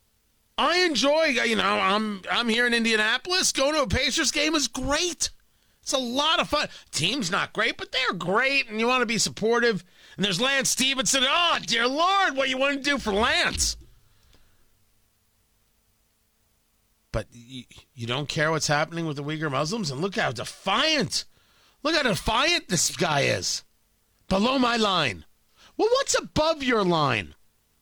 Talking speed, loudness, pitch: 165 wpm, -23 LUFS, 235 Hz